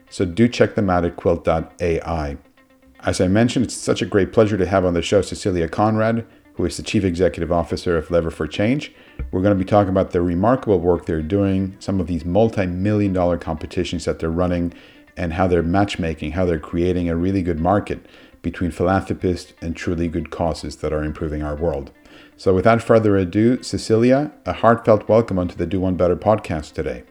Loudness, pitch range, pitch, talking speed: -20 LUFS, 85-105 Hz, 90 Hz, 195 wpm